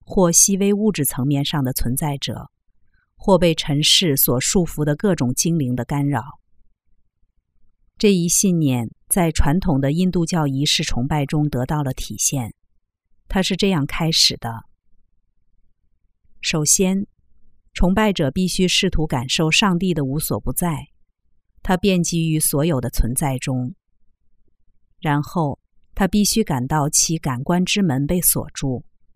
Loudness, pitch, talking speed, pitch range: -19 LUFS, 145 Hz, 200 characters per minute, 120-175 Hz